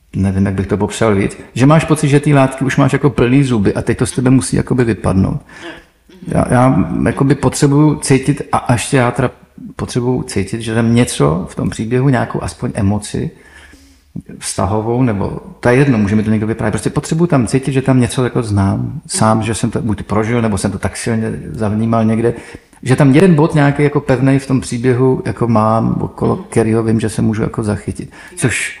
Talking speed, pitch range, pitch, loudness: 200 wpm, 110-135 Hz, 120 Hz, -14 LUFS